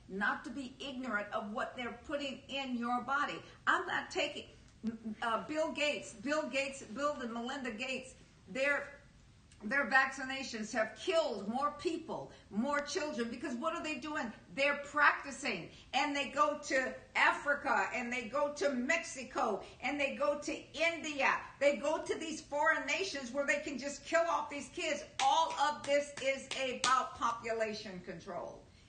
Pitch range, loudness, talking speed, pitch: 250-295 Hz, -35 LUFS, 155 wpm, 280 Hz